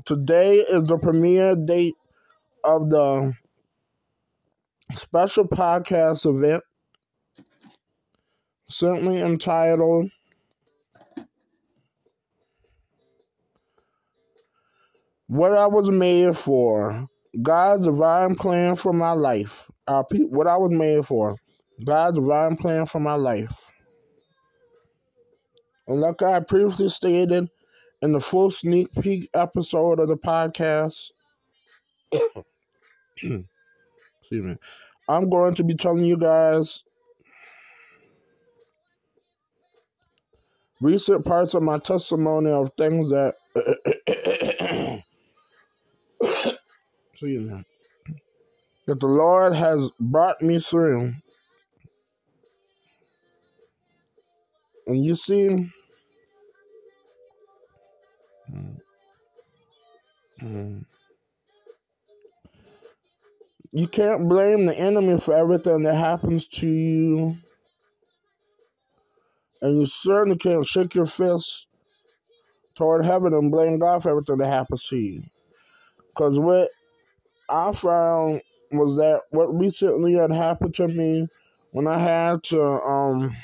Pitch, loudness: 175 Hz, -21 LUFS